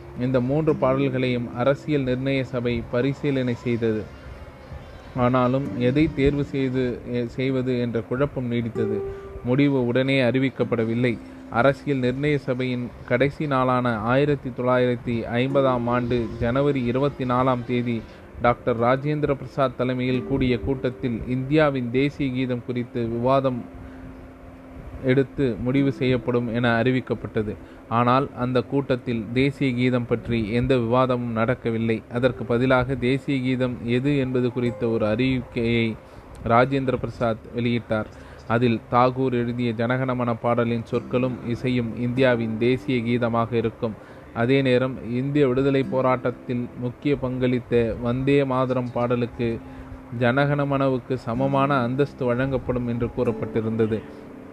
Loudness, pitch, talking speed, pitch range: -23 LUFS, 125 Hz, 105 wpm, 120-130 Hz